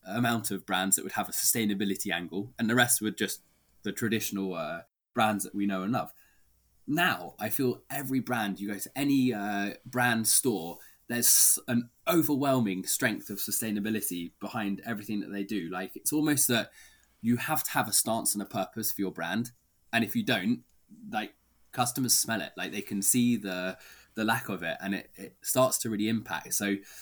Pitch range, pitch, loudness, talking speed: 100-125 Hz, 110 Hz, -29 LUFS, 195 wpm